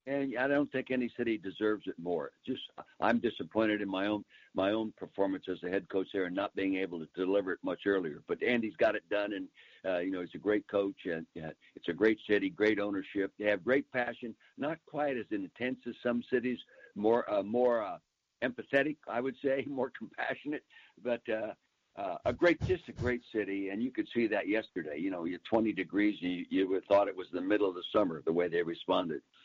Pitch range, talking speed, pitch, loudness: 95-125 Hz, 225 wpm, 105 Hz, -34 LUFS